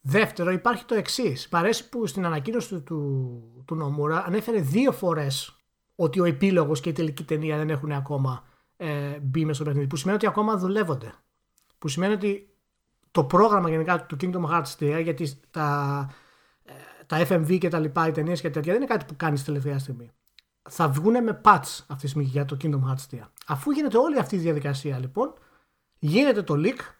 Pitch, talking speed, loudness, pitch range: 160 Hz, 190 wpm, -25 LUFS, 145-190 Hz